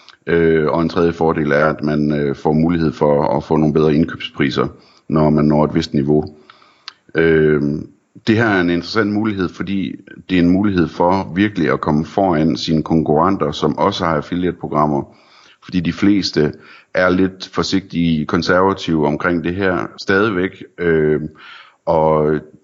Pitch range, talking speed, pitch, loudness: 75-90 Hz, 145 wpm, 80 Hz, -16 LUFS